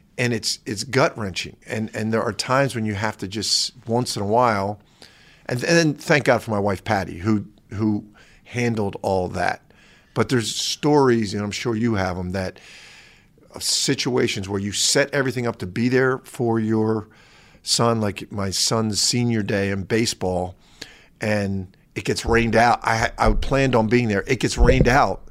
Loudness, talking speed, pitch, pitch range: -21 LUFS, 185 wpm, 110 Hz, 100-120 Hz